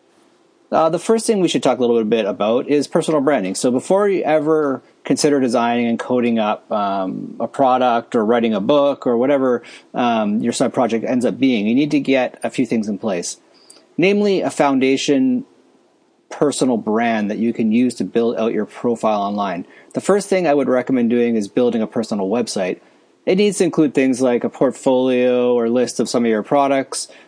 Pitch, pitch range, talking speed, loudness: 130 Hz, 120-195 Hz, 200 wpm, -18 LUFS